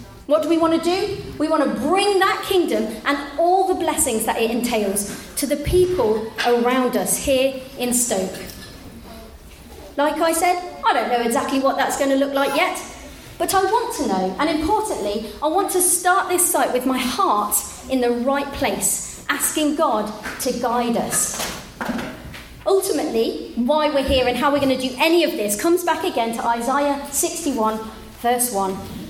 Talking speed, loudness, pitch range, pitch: 180 wpm, -20 LUFS, 240-340 Hz, 280 Hz